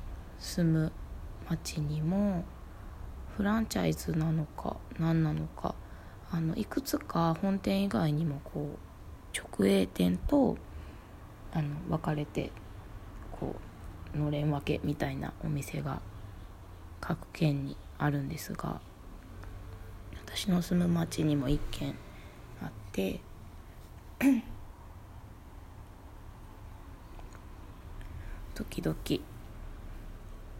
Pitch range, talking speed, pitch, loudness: 90-150 Hz, 150 characters per minute, 100 Hz, -33 LUFS